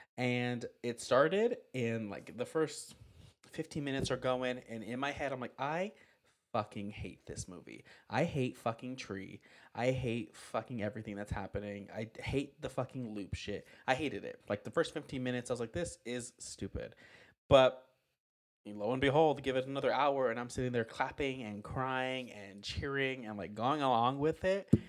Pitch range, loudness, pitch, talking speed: 110-135 Hz, -36 LUFS, 125 Hz, 180 wpm